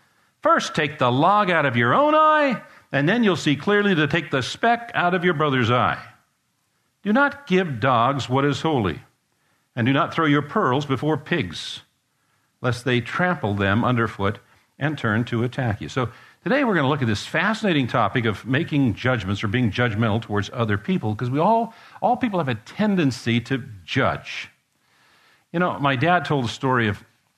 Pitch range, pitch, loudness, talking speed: 120-180 Hz, 135 Hz, -21 LUFS, 185 wpm